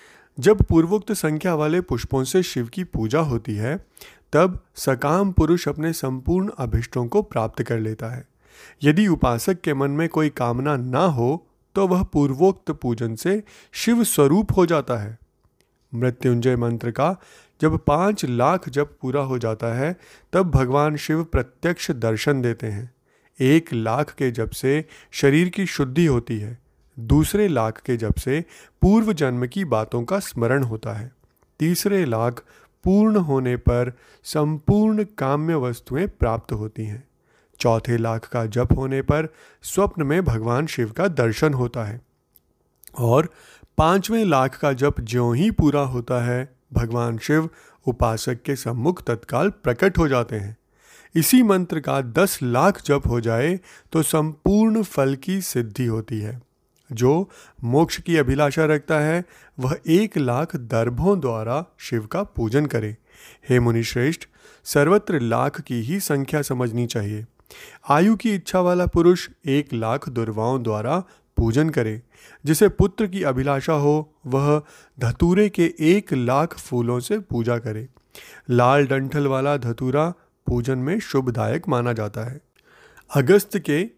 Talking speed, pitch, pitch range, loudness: 145 wpm, 140 Hz, 120-165 Hz, -21 LUFS